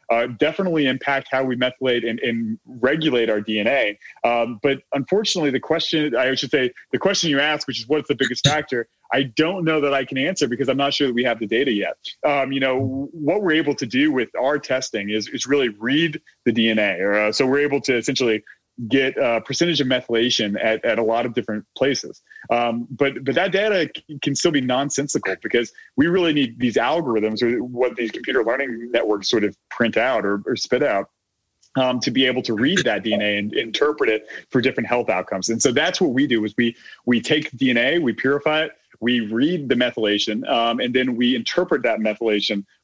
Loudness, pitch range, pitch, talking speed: -20 LUFS, 115-145 Hz, 130 Hz, 210 wpm